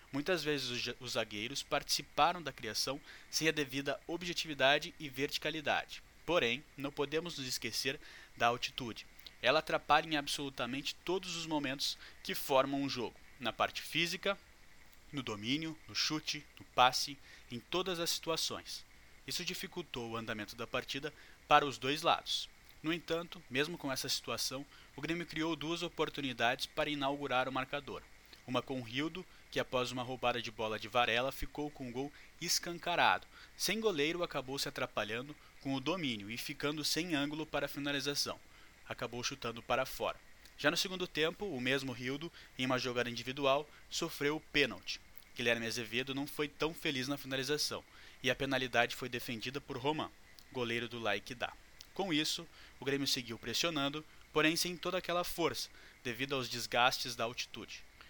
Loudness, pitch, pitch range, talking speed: -36 LUFS, 140 Hz, 125-155 Hz, 155 wpm